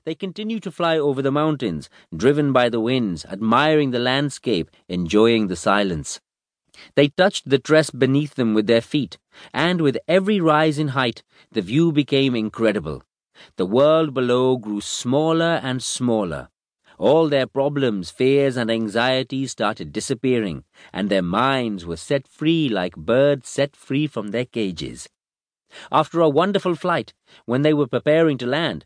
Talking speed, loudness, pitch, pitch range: 155 wpm, -20 LUFS, 135 Hz, 115-150 Hz